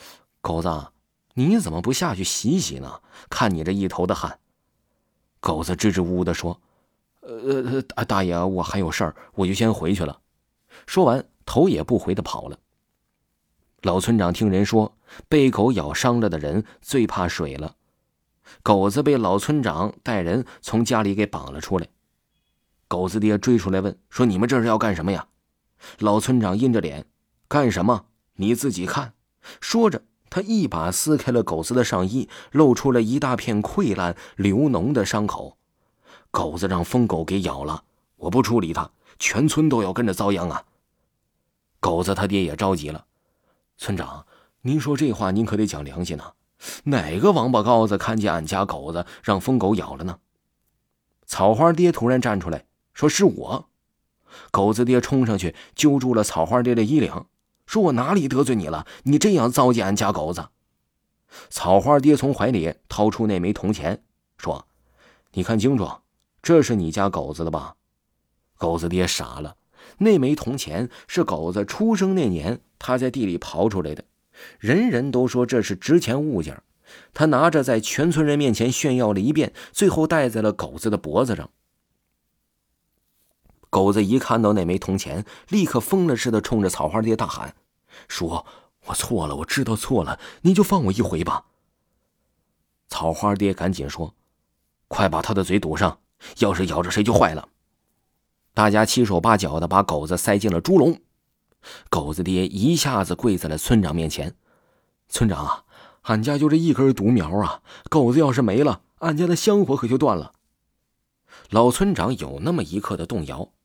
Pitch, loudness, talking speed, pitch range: 105 Hz, -21 LUFS, 240 characters per minute, 90-125 Hz